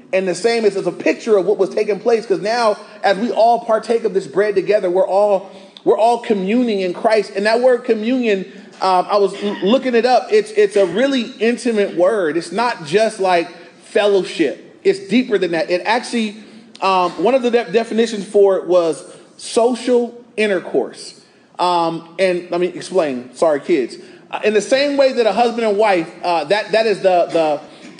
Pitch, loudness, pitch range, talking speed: 210 Hz, -16 LUFS, 190-235 Hz, 195 wpm